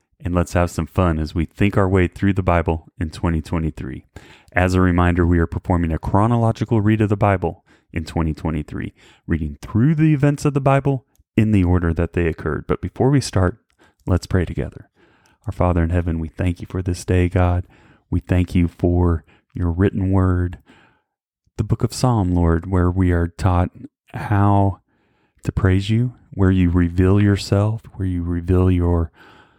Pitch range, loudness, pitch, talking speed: 85-100 Hz, -19 LUFS, 90 Hz, 180 wpm